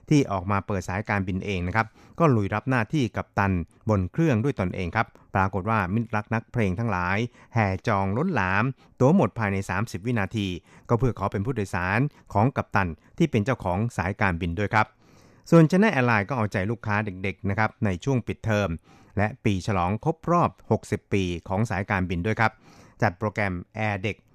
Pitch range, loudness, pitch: 95-115 Hz, -25 LUFS, 105 Hz